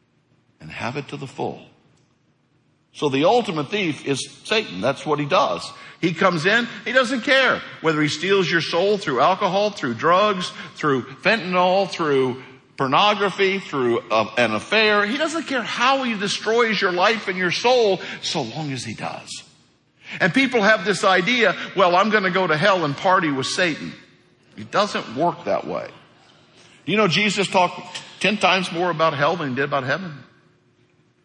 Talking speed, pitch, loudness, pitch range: 175 wpm, 185 Hz, -20 LUFS, 150-210 Hz